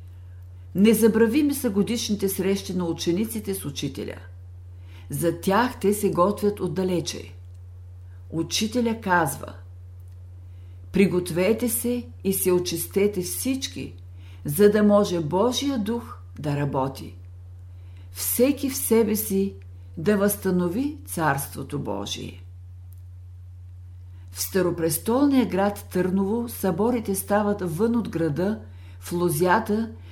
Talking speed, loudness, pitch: 95 wpm, -24 LUFS, 170 Hz